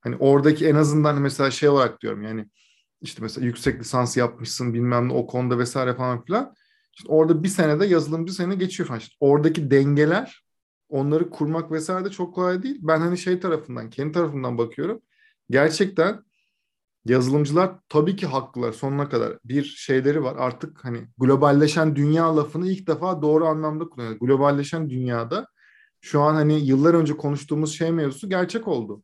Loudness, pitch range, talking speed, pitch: -22 LUFS, 130-170 Hz, 165 wpm, 150 Hz